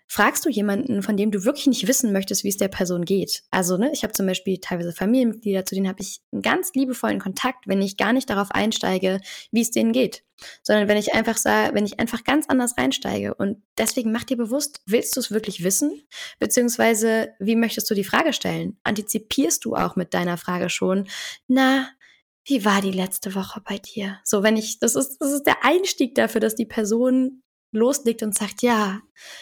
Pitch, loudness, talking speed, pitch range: 220 Hz, -22 LUFS, 210 wpm, 195-255 Hz